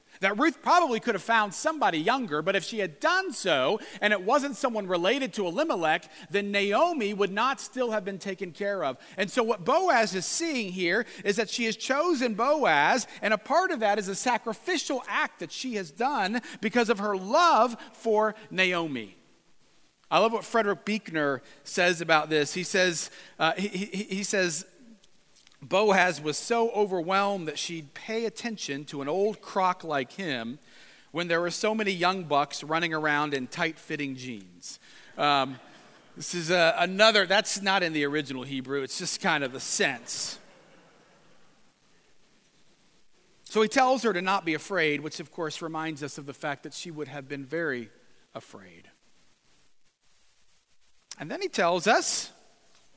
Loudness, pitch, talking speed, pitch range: -27 LUFS, 195 Hz, 170 wpm, 160-225 Hz